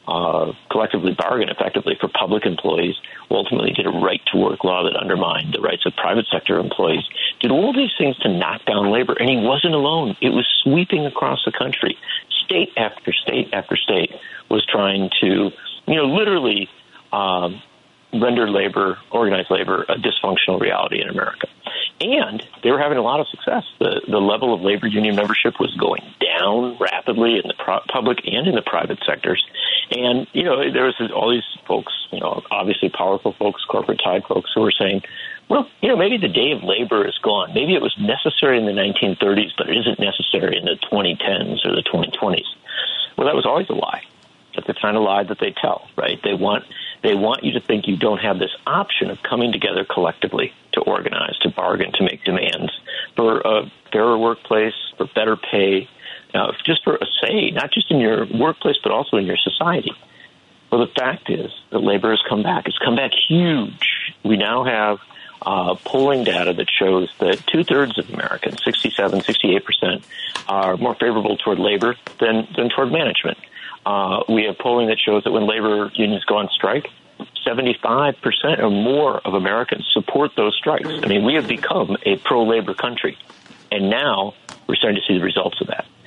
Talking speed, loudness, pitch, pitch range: 190 wpm, -19 LUFS, 110 Hz, 105-125 Hz